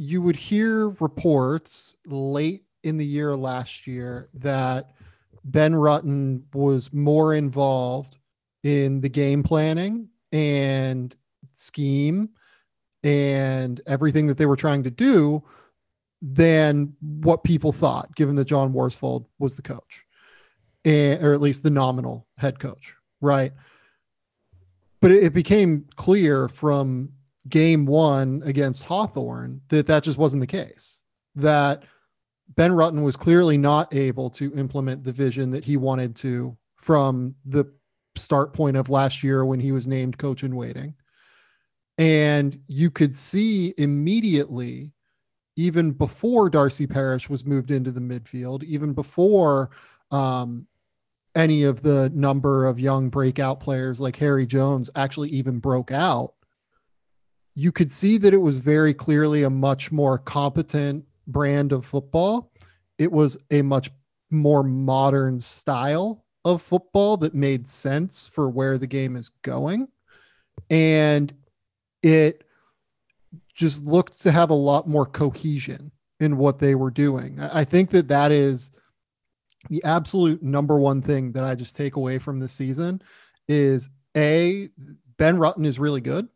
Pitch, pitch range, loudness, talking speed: 140 Hz, 135-155 Hz, -22 LUFS, 140 wpm